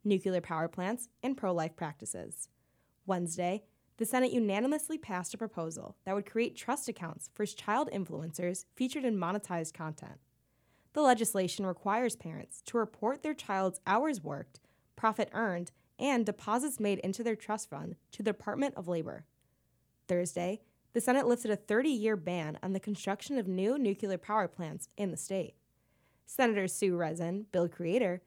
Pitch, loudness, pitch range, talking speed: 200 Hz, -34 LUFS, 180-230 Hz, 155 wpm